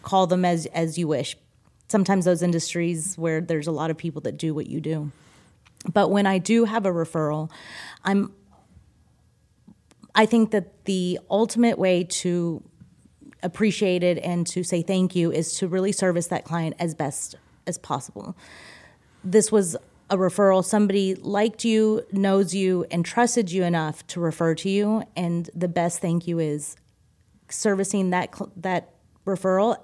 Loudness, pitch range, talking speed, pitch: -24 LUFS, 165-195 Hz, 160 wpm, 180 Hz